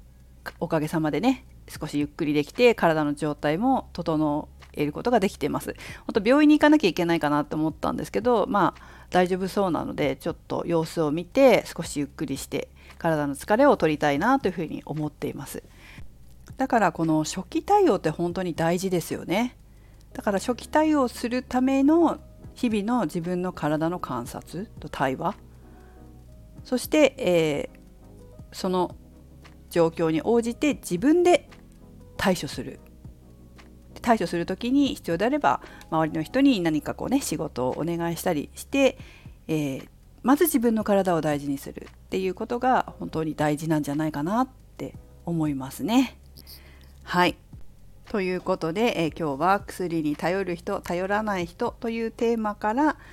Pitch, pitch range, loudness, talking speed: 170 Hz, 150-235 Hz, -25 LUFS, 315 characters per minute